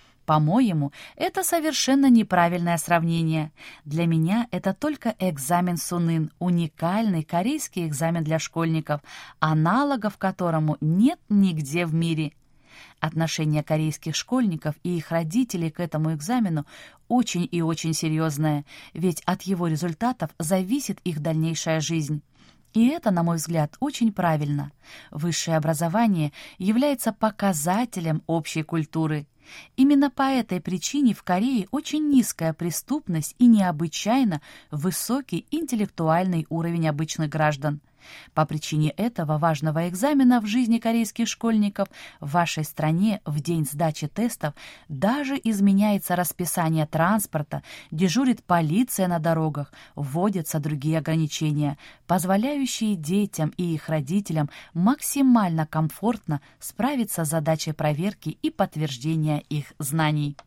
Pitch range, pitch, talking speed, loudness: 155-210 Hz, 170 Hz, 115 wpm, -24 LUFS